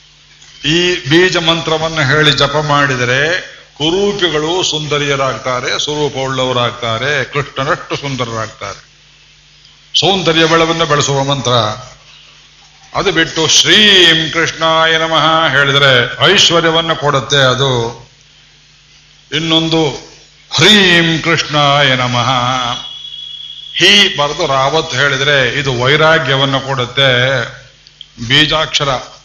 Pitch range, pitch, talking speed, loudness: 135-160 Hz, 145 Hz, 75 wpm, -11 LUFS